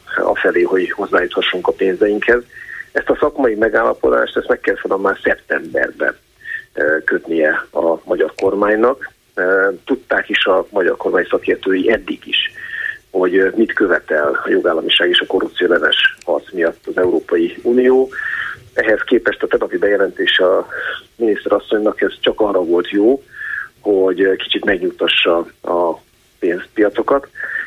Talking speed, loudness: 130 wpm, -16 LUFS